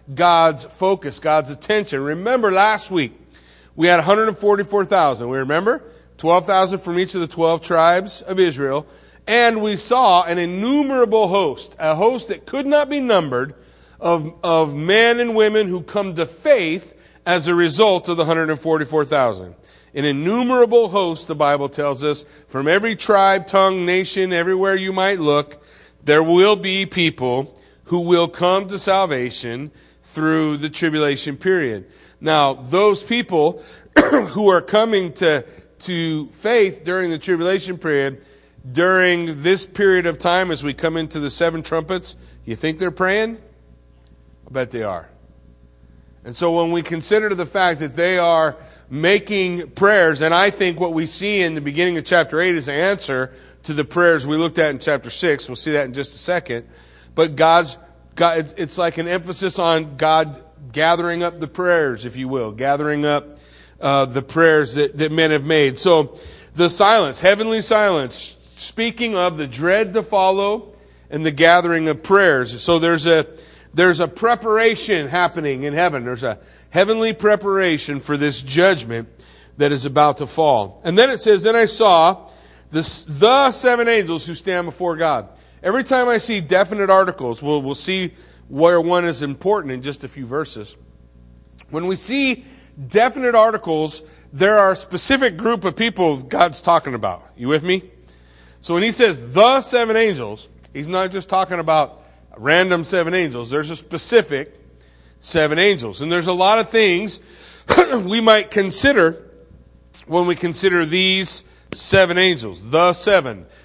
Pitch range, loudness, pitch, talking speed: 145-195 Hz, -17 LUFS, 170 Hz, 160 wpm